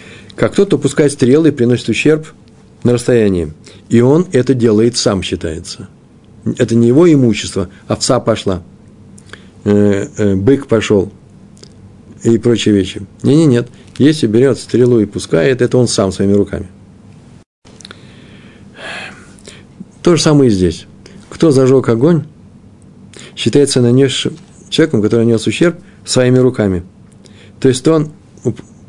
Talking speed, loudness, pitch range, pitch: 125 wpm, -12 LUFS, 100-130 Hz, 115 Hz